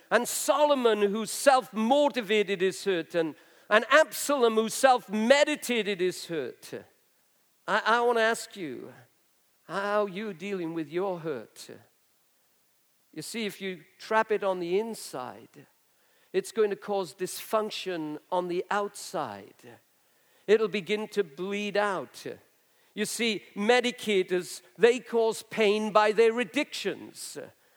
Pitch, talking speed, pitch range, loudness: 210 Hz, 125 wpm, 190-235 Hz, -27 LUFS